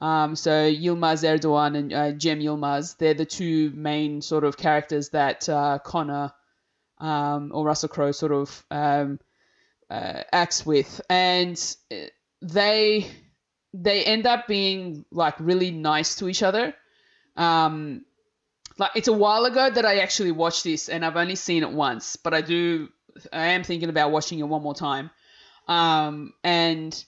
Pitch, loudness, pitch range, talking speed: 160 Hz, -23 LUFS, 150-180 Hz, 155 wpm